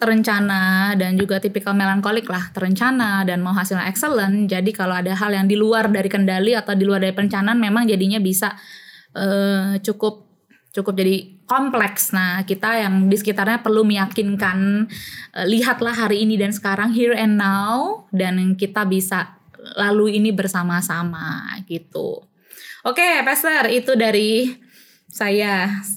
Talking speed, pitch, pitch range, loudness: 145 wpm, 205 Hz, 195-225 Hz, -19 LUFS